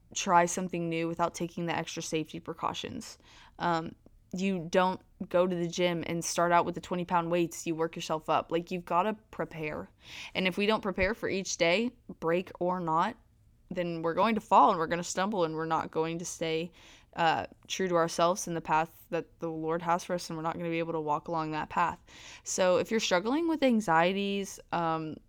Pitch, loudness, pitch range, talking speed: 170 Hz, -30 LUFS, 165-185 Hz, 220 wpm